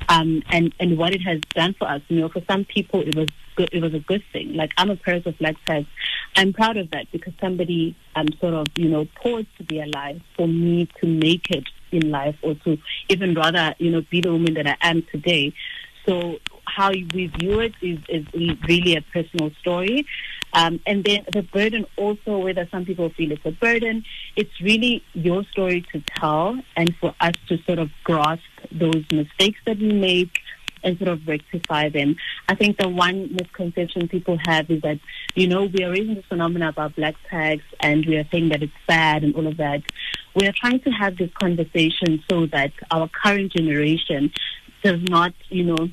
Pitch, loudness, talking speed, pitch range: 170 Hz, -21 LUFS, 205 wpm, 160-190 Hz